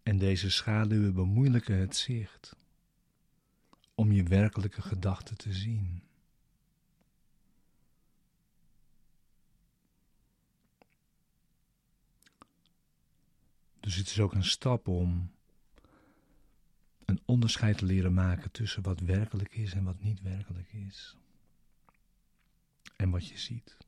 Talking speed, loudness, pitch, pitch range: 95 wpm, -31 LUFS, 100 Hz, 95-110 Hz